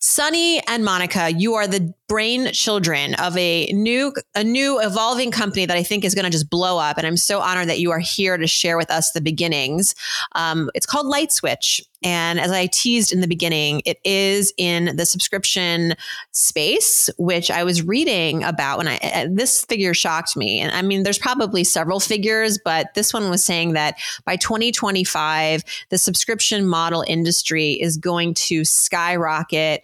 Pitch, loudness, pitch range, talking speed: 180 Hz, -18 LUFS, 165-210 Hz, 180 wpm